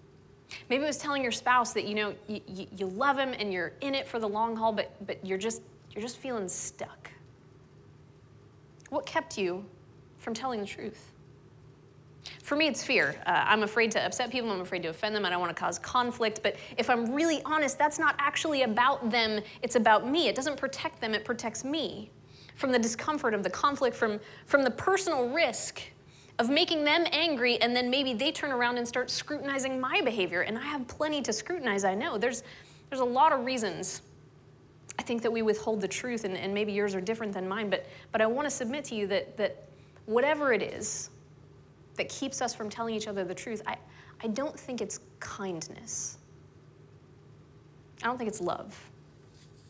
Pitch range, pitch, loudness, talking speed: 200-270 Hz, 230 Hz, -30 LUFS, 200 wpm